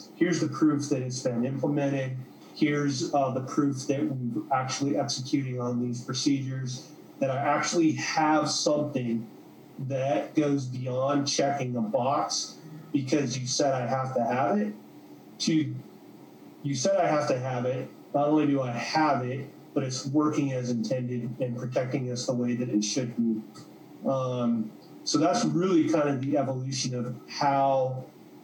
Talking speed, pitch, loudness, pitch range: 160 wpm, 135 Hz, -28 LUFS, 125-145 Hz